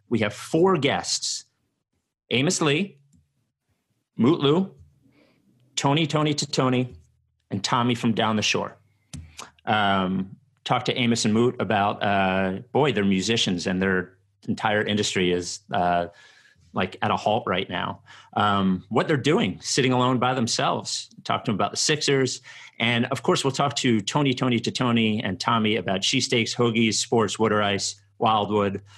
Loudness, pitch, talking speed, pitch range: -23 LUFS, 115 Hz, 155 wpm, 100-130 Hz